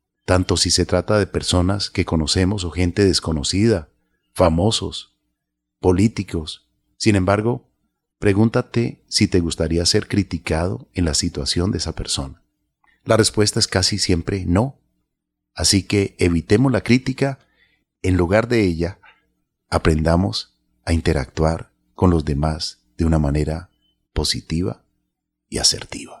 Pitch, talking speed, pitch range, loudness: 90 Hz, 125 wpm, 80-100 Hz, -19 LUFS